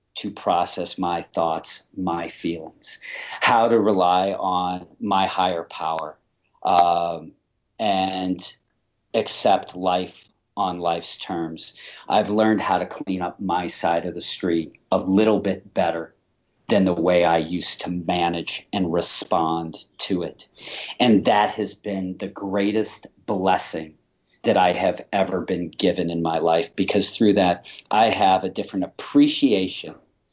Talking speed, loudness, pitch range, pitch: 140 wpm, -22 LUFS, 85-100 Hz, 90 Hz